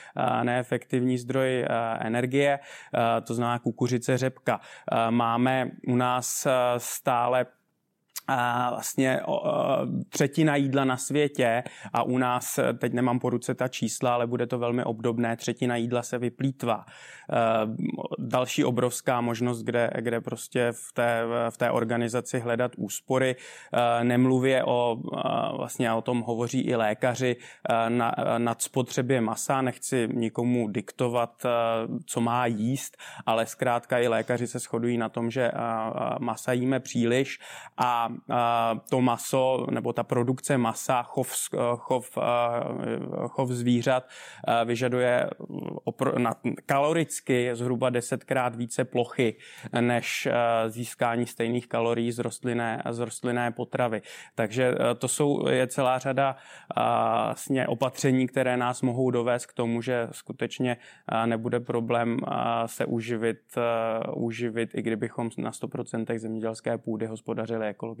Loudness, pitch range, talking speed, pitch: -27 LUFS, 115-125 Hz, 115 wpm, 120 Hz